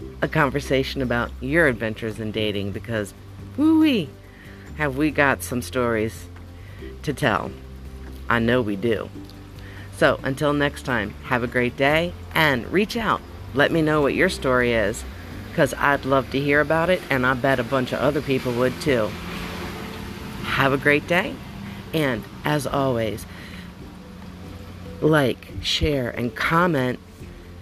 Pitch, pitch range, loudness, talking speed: 115 Hz, 95-135 Hz, -22 LUFS, 145 wpm